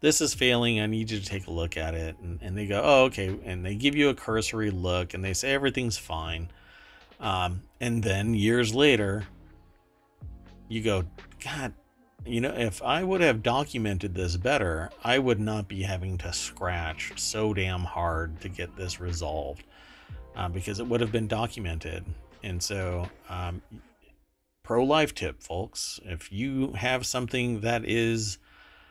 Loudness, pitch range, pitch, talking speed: -28 LUFS, 90-115 Hz, 100 Hz, 170 wpm